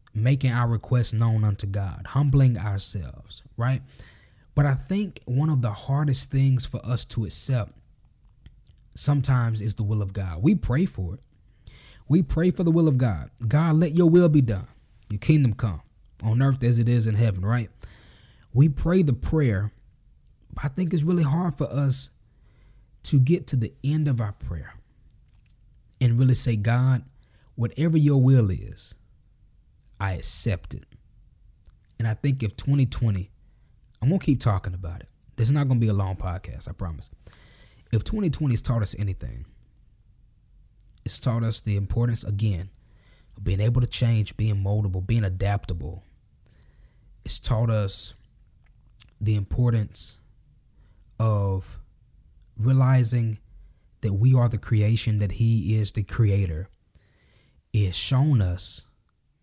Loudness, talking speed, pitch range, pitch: -24 LUFS, 150 wpm, 100-130 Hz, 115 Hz